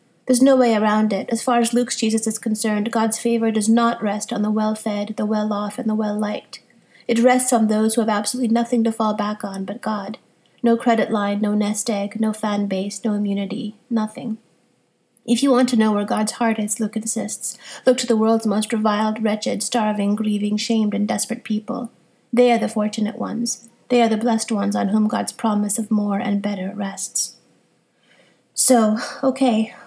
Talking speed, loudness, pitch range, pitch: 200 wpm, -20 LUFS, 210-235 Hz, 220 Hz